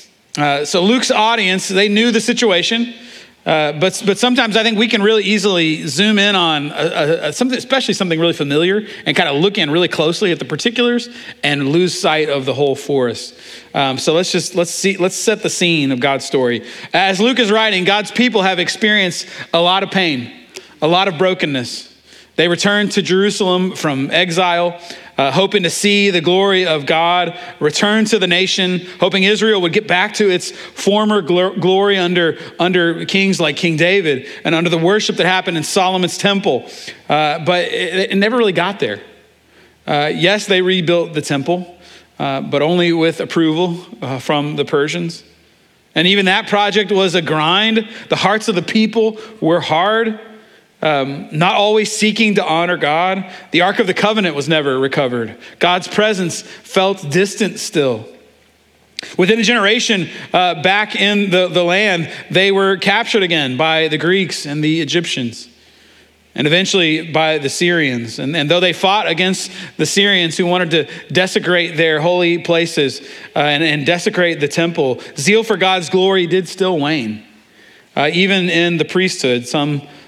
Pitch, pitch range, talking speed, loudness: 180 Hz, 160-200 Hz, 175 wpm, -14 LUFS